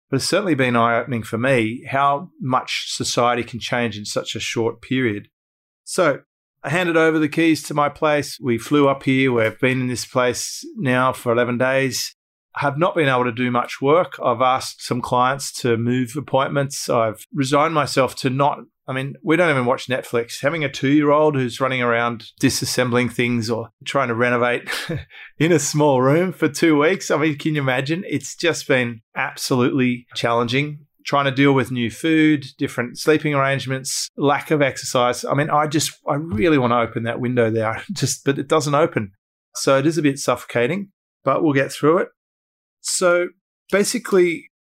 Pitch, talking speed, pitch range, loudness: 135 Hz, 190 wpm, 120-150 Hz, -20 LUFS